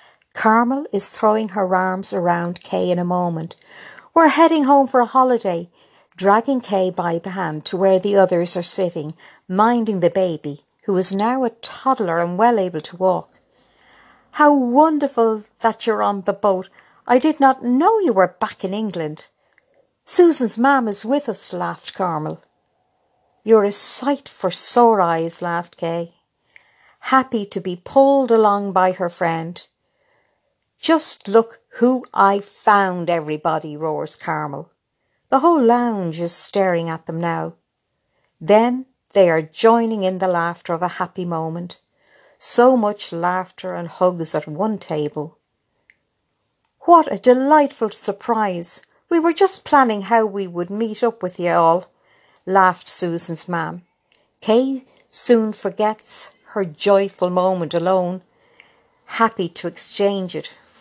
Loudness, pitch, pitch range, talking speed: -17 LUFS, 195 Hz, 175-235 Hz, 140 wpm